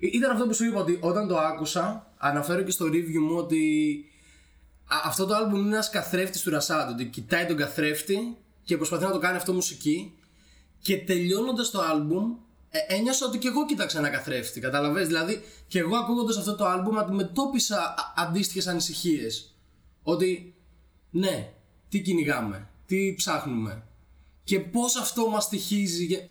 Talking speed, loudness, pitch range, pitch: 155 wpm, -27 LUFS, 150-205 Hz, 180 Hz